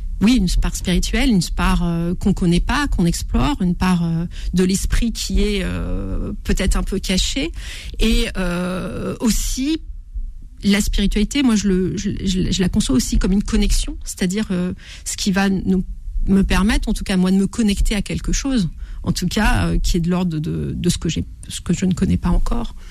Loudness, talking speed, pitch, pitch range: -20 LUFS, 205 wpm, 190 Hz, 175-210 Hz